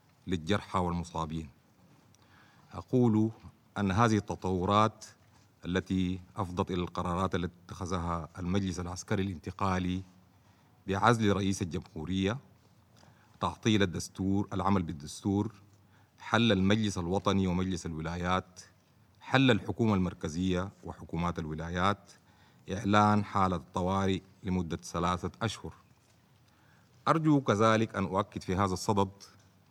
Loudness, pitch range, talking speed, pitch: -31 LUFS, 90-105 Hz, 90 wpm, 95 Hz